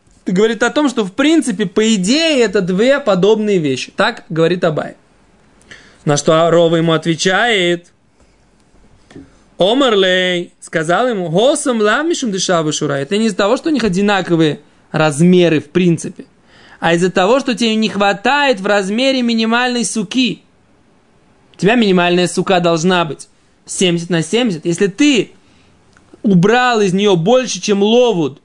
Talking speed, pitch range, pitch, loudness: 135 wpm, 175-235 Hz, 200 Hz, -14 LUFS